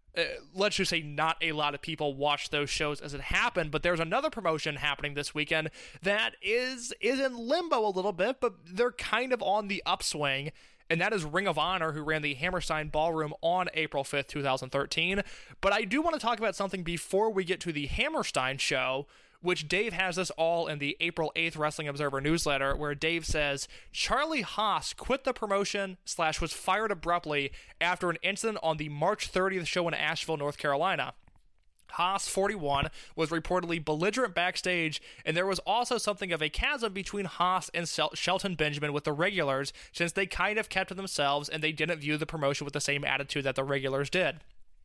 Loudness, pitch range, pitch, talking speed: -30 LUFS, 150-195 Hz, 165 Hz, 200 wpm